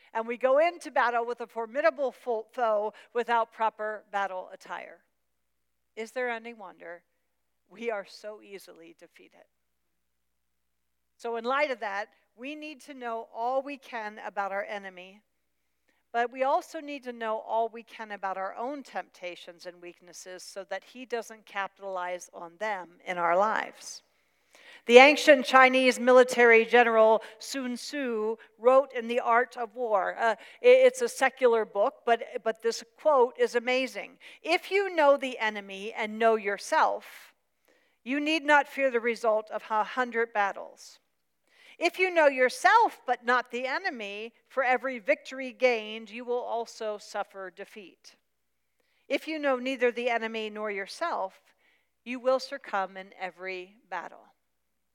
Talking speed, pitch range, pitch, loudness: 145 wpm, 200-260 Hz, 230 Hz, -27 LUFS